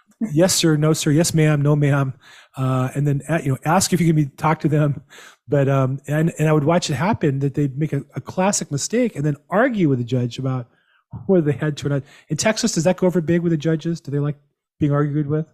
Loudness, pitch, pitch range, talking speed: -20 LUFS, 155 Hz, 145-170 Hz, 260 wpm